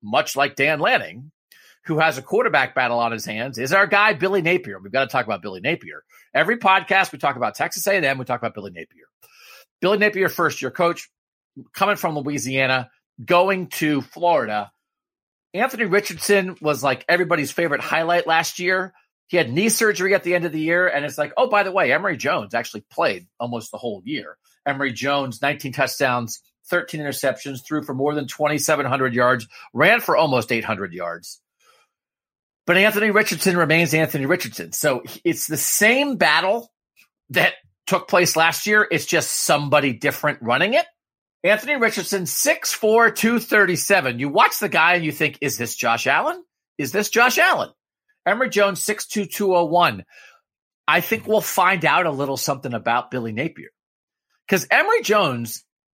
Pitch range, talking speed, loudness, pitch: 135-195 Hz, 170 wpm, -20 LUFS, 165 Hz